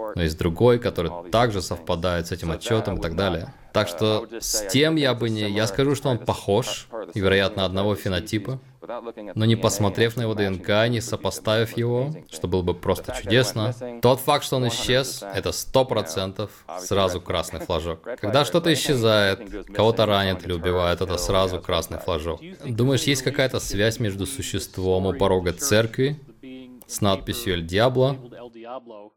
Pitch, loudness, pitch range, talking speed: 110 Hz, -23 LUFS, 95-125 Hz, 155 wpm